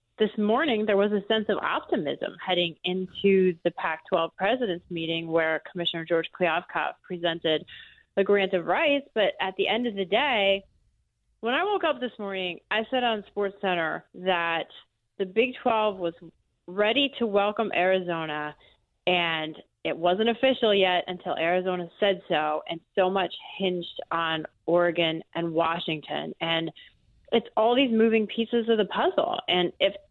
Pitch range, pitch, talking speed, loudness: 170-220 Hz, 190 Hz, 155 wpm, -26 LUFS